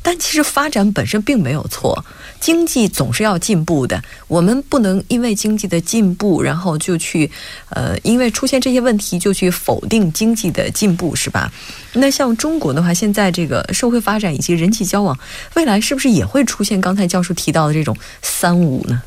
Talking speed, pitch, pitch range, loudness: 300 characters per minute, 200 Hz, 170-240 Hz, -16 LUFS